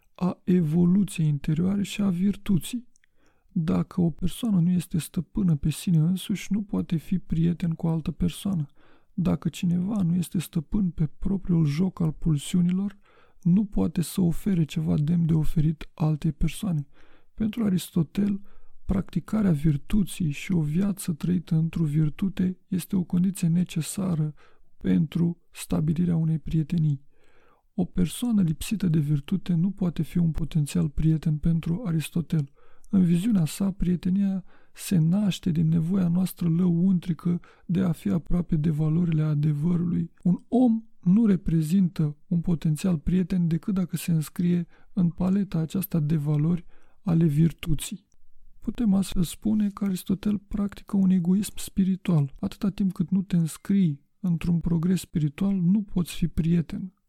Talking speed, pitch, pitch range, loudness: 140 wpm, 175 Hz, 165-190 Hz, -26 LUFS